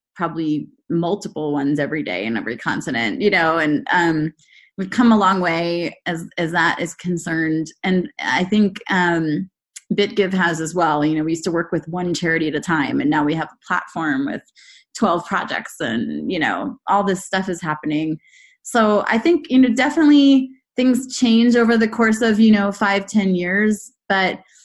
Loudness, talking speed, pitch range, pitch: -19 LUFS, 185 wpm, 165-230 Hz, 190 Hz